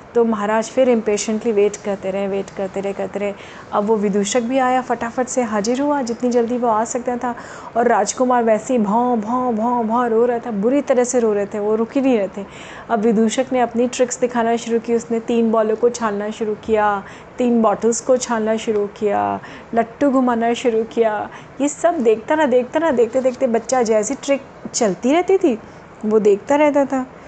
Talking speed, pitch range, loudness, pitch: 205 wpm, 215-250 Hz, -18 LUFS, 235 Hz